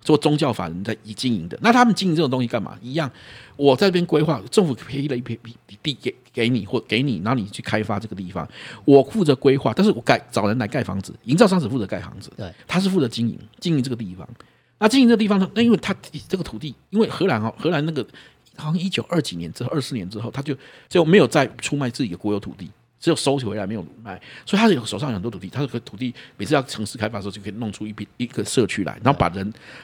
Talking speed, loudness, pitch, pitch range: 390 characters per minute, -21 LUFS, 130 Hz, 110-165 Hz